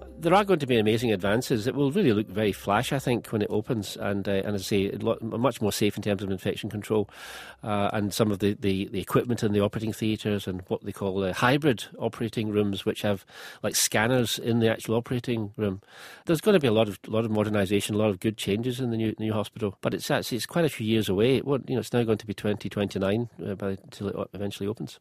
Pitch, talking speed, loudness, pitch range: 110 Hz, 250 wpm, -27 LUFS, 100-115 Hz